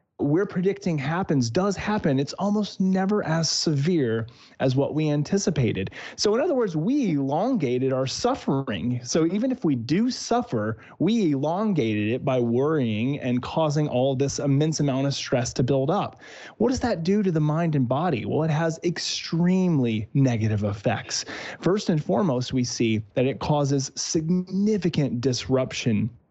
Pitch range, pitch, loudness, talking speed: 130-180 Hz, 150 Hz, -24 LUFS, 155 wpm